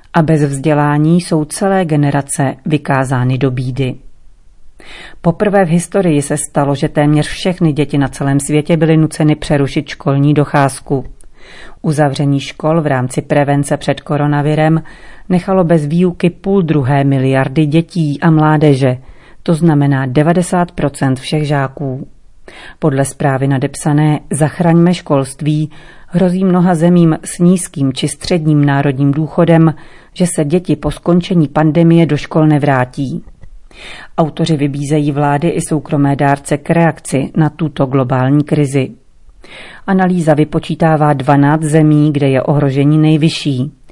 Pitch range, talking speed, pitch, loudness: 140-165 Hz, 125 wpm, 150 Hz, -13 LUFS